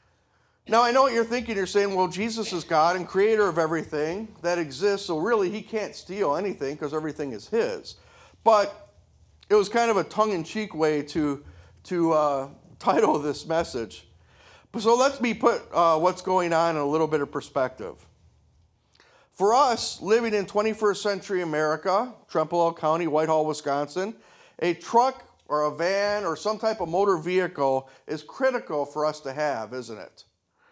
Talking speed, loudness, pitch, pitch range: 170 wpm, -25 LUFS, 170 Hz, 150-210 Hz